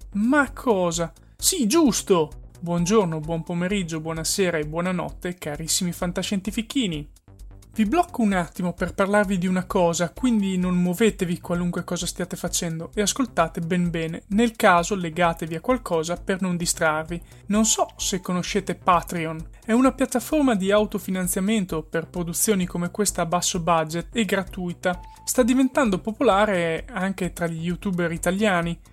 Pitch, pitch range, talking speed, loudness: 180 Hz, 170-210 Hz, 140 wpm, -23 LUFS